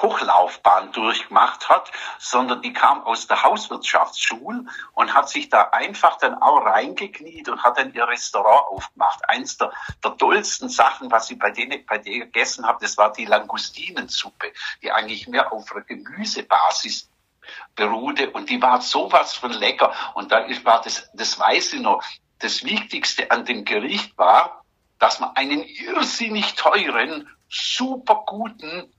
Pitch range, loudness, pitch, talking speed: 215-275 Hz, -20 LUFS, 235 Hz, 155 wpm